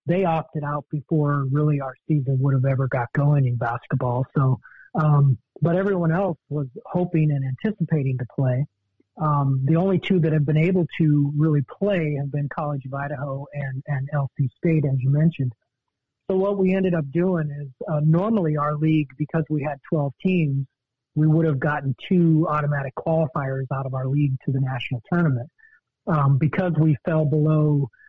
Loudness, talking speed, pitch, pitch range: -23 LUFS, 180 wpm, 150 Hz, 135-160 Hz